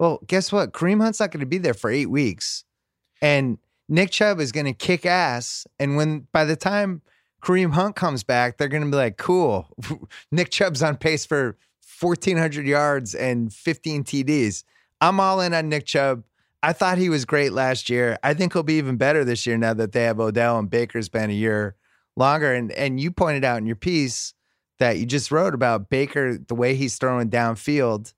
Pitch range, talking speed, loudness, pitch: 120-165 Hz, 205 wpm, -22 LUFS, 140 Hz